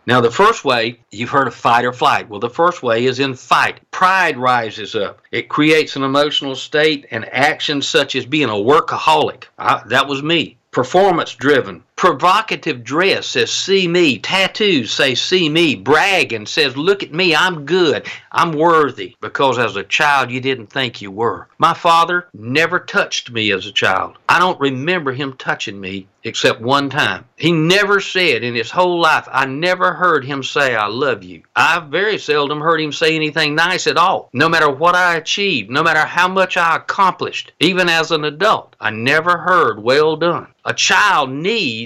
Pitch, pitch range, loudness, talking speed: 150 Hz, 130-175 Hz, -15 LUFS, 185 wpm